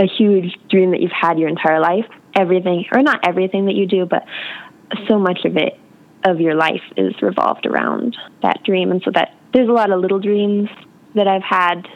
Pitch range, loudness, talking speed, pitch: 180-205 Hz, -17 LUFS, 205 wpm, 190 Hz